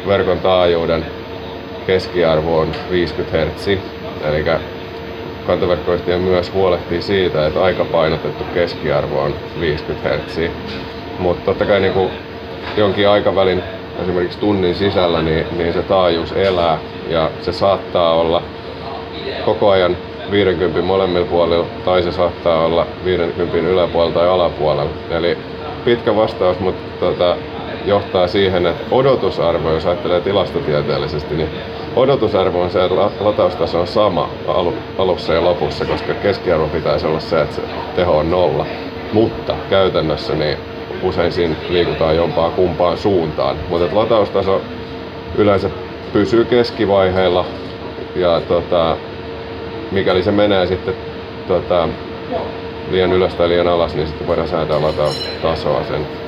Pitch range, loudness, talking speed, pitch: 85-95 Hz, -16 LUFS, 120 wpm, 90 Hz